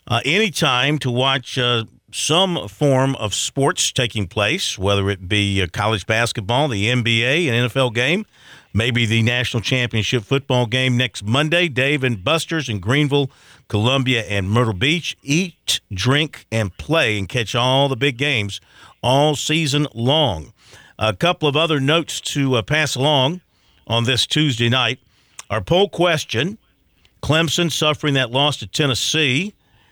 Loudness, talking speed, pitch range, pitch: -18 LUFS, 150 wpm, 110-150 Hz, 130 Hz